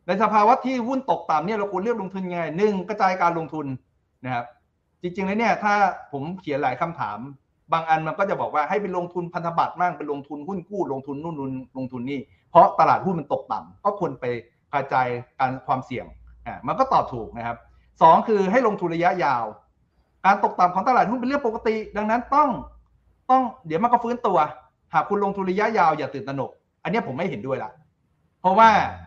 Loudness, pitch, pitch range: -23 LUFS, 180 Hz, 140-215 Hz